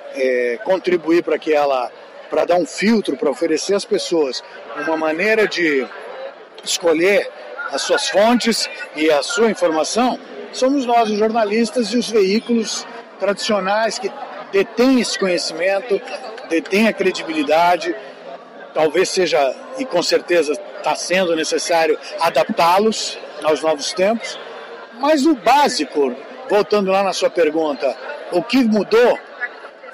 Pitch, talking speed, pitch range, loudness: 195 Hz, 120 wpm, 165-235 Hz, -17 LUFS